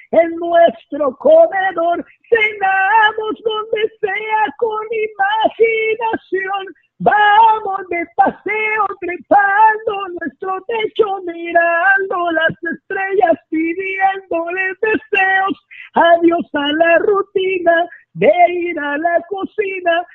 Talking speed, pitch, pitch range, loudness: 85 wpm, 385 Hz, 335-425 Hz, -15 LUFS